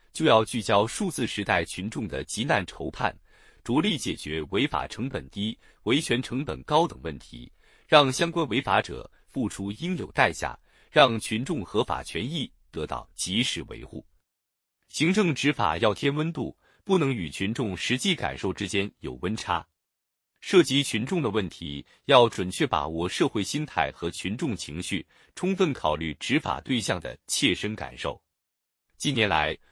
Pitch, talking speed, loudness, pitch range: 110 Hz, 235 characters per minute, -26 LUFS, 90-150 Hz